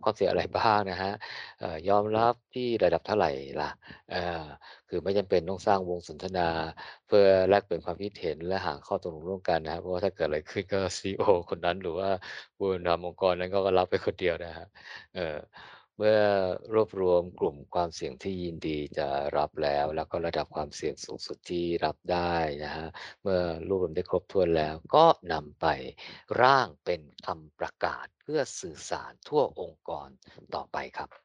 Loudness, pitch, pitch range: -29 LUFS, 90 Hz, 85-100 Hz